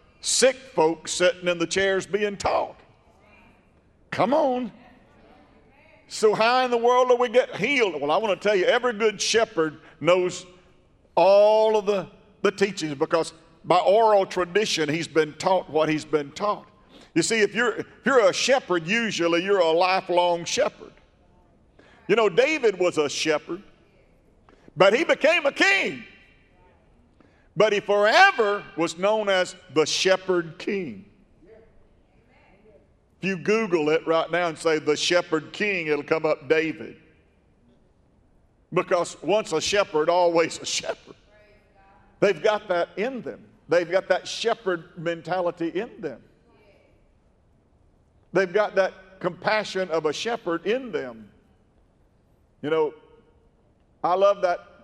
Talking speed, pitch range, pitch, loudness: 140 wpm, 165-215 Hz, 185 Hz, -23 LUFS